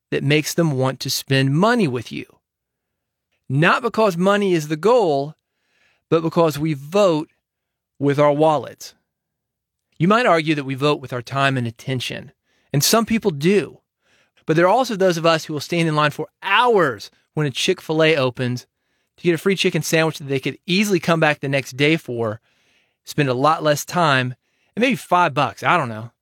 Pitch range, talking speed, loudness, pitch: 135-175 Hz, 195 wpm, -19 LUFS, 155 Hz